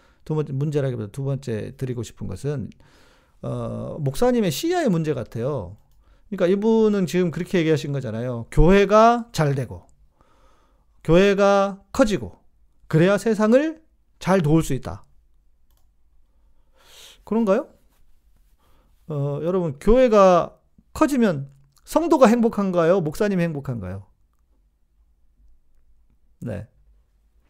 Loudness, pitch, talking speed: -21 LUFS, 140 Hz, 235 characters per minute